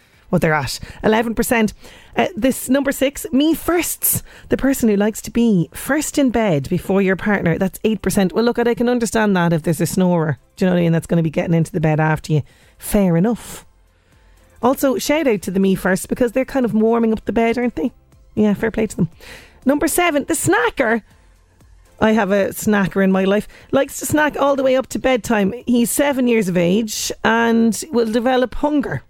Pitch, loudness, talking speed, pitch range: 220 Hz, -18 LUFS, 210 wpm, 175-250 Hz